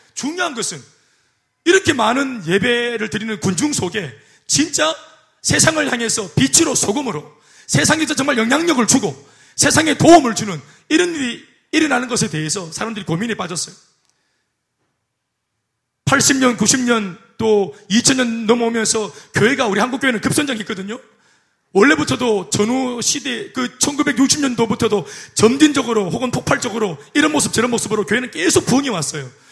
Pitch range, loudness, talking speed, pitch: 210-275 Hz, -16 LUFS, 310 characters per minute, 230 Hz